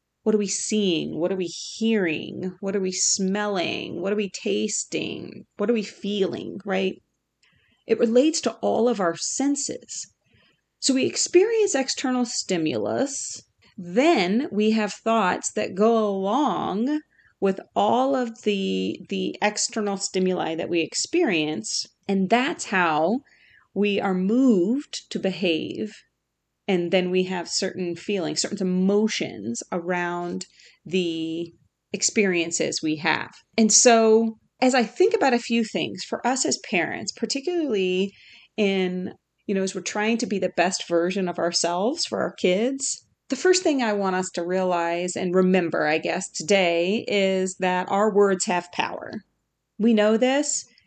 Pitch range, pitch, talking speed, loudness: 180-230 Hz, 200 Hz, 145 wpm, -23 LUFS